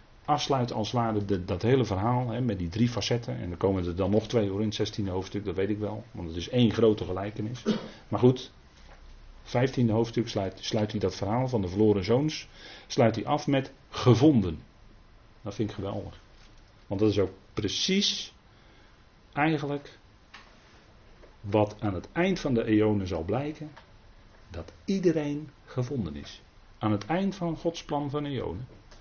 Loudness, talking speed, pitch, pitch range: -28 LUFS, 170 wpm, 110 Hz, 100-125 Hz